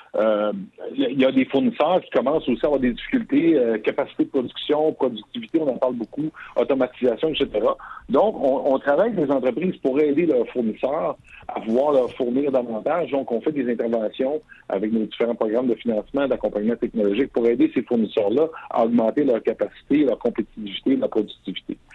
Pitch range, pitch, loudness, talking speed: 115-155 Hz, 135 Hz, -22 LUFS, 180 wpm